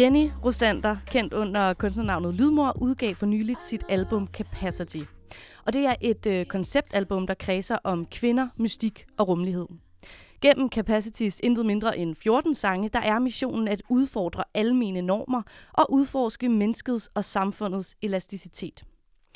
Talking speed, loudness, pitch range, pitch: 140 wpm, -26 LUFS, 190-245 Hz, 215 Hz